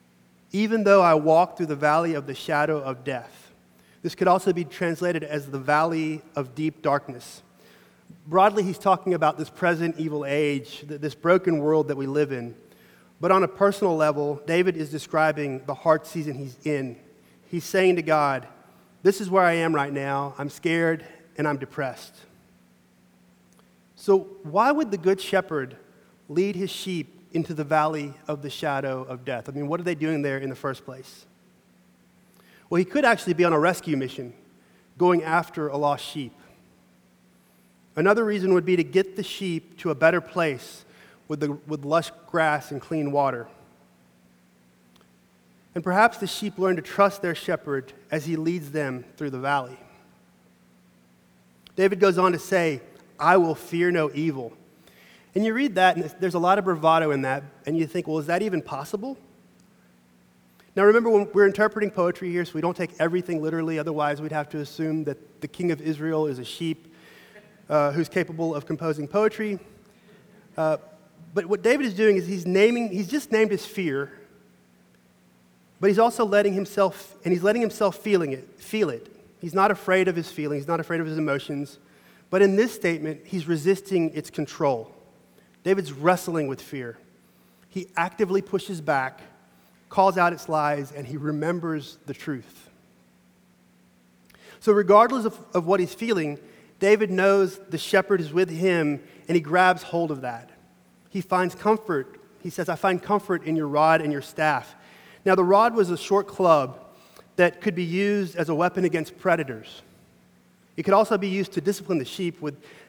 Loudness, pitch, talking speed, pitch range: -24 LUFS, 160 Hz, 175 wpm, 140-190 Hz